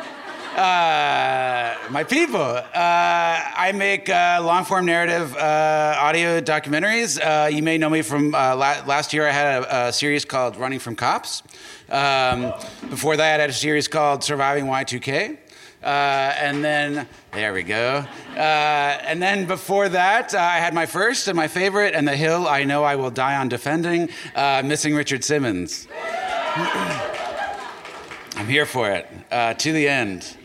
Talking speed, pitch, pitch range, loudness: 160 wpm, 150 Hz, 140-170 Hz, -20 LUFS